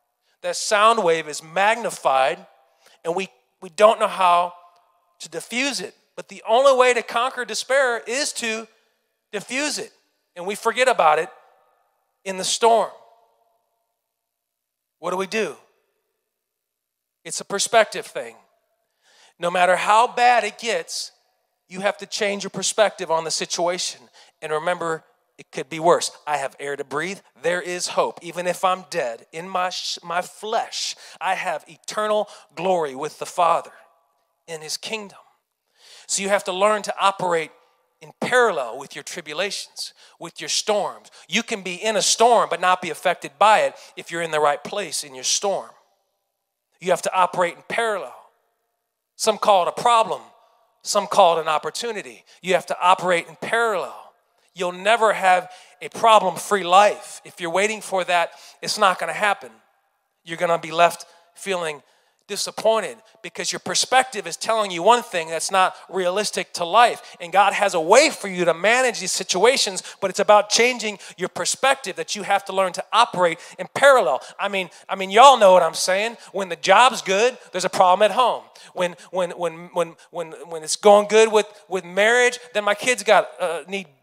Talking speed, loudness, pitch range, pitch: 175 wpm, -20 LUFS, 175-220 Hz, 190 Hz